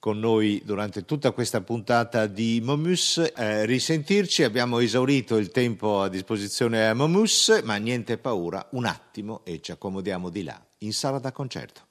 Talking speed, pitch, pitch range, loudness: 160 wpm, 115 Hz, 105-135 Hz, -24 LUFS